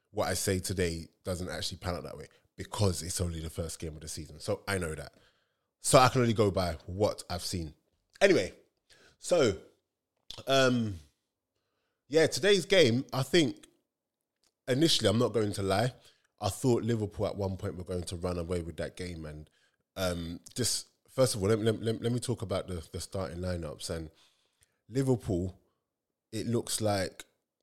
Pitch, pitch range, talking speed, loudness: 95 Hz, 90-115 Hz, 180 wpm, -31 LUFS